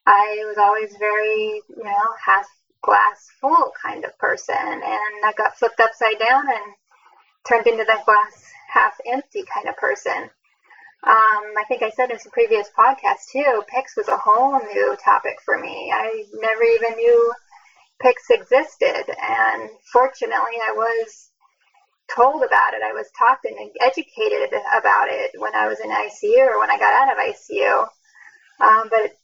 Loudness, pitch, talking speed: -19 LUFS, 260 Hz, 165 wpm